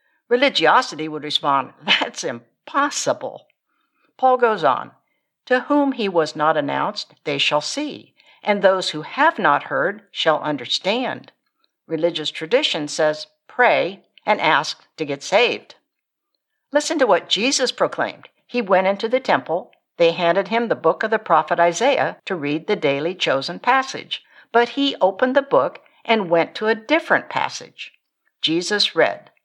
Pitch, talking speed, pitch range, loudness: 205 Hz, 145 wpm, 160-255 Hz, -19 LUFS